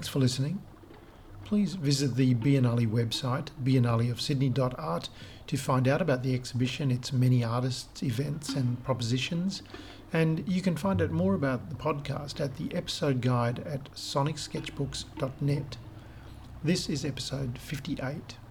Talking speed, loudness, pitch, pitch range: 130 wpm, -30 LUFS, 135 Hz, 120-150 Hz